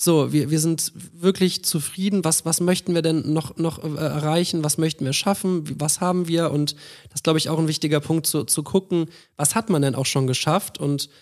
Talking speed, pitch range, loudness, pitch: 220 wpm, 150-175 Hz, -22 LUFS, 160 Hz